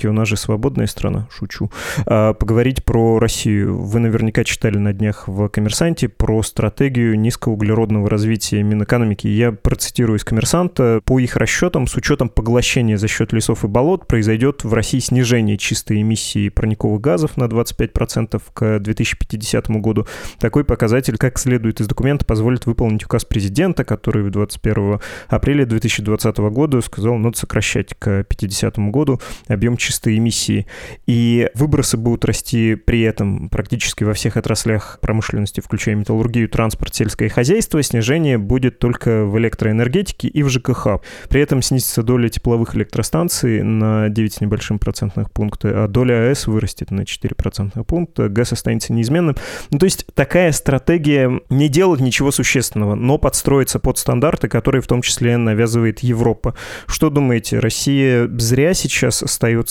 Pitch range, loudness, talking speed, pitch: 110-130 Hz, -17 LUFS, 145 wpm, 115 Hz